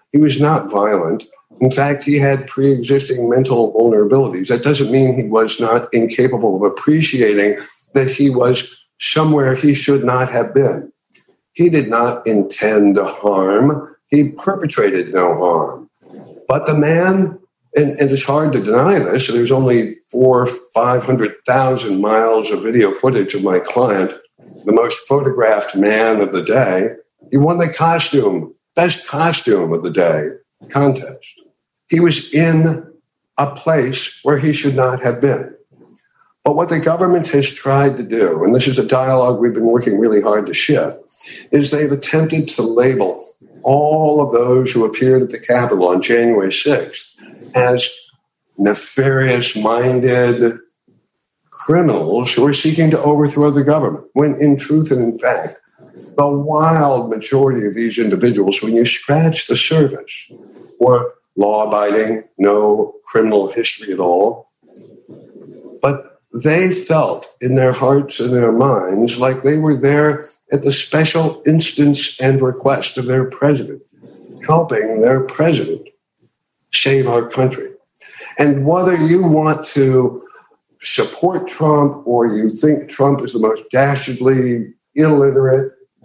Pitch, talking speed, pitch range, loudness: 135 Hz, 140 wpm, 120-150 Hz, -14 LUFS